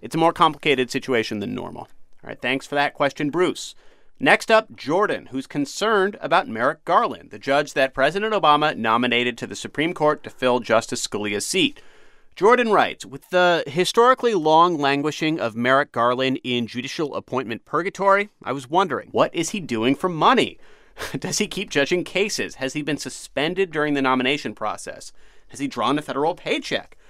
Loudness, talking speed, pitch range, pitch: -21 LUFS, 175 wpm, 130-180 Hz, 145 Hz